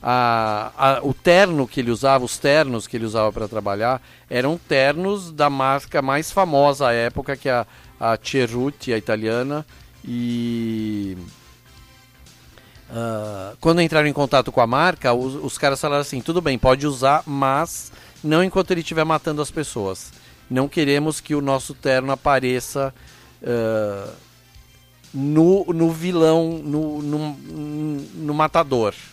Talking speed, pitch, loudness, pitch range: 145 wpm, 135 Hz, -20 LUFS, 120-150 Hz